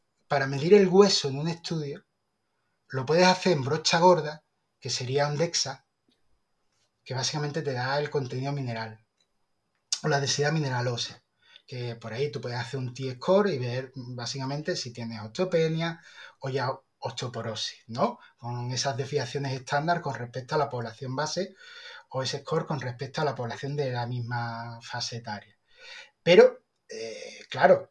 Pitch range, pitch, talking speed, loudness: 125-165 Hz, 140 Hz, 155 wpm, -27 LUFS